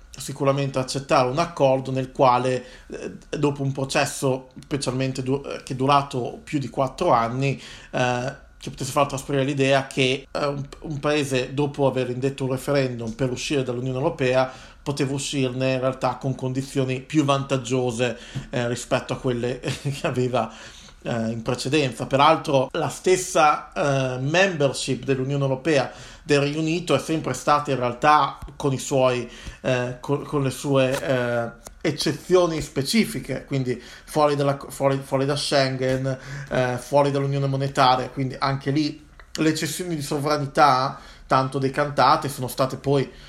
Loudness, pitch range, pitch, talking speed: -23 LUFS, 130-145 Hz, 135 Hz, 145 wpm